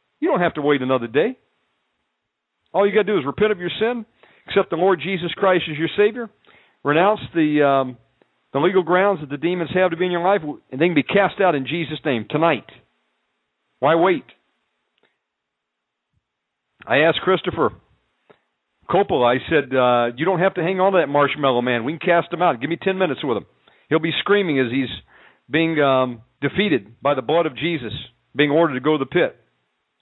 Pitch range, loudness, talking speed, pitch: 135-185 Hz, -19 LUFS, 200 wpm, 165 Hz